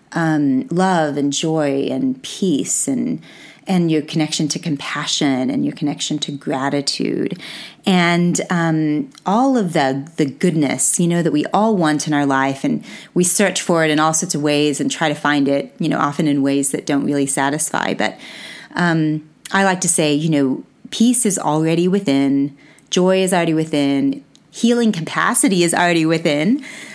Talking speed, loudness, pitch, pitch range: 175 wpm, -17 LUFS, 155 Hz, 145-180 Hz